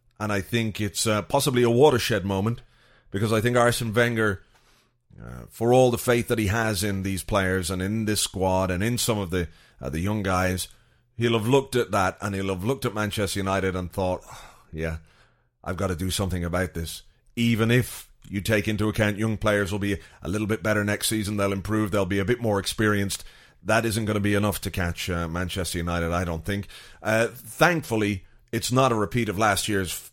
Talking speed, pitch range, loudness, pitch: 215 wpm, 95-115 Hz, -25 LUFS, 105 Hz